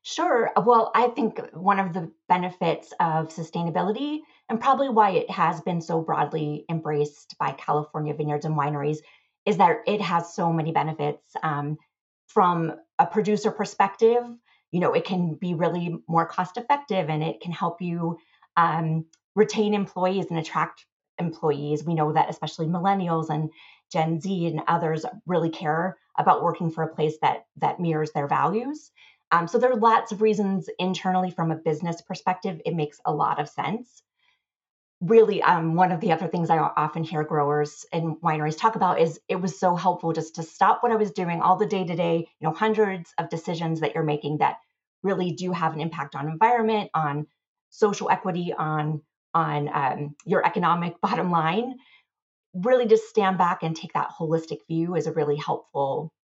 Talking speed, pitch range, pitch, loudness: 180 wpm, 160-200 Hz, 170 Hz, -25 LUFS